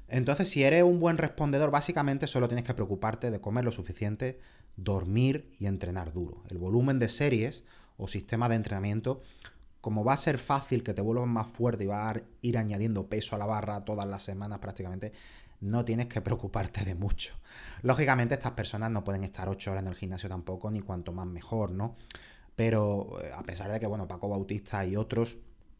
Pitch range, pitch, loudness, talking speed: 100-120 Hz, 110 Hz, -31 LUFS, 195 wpm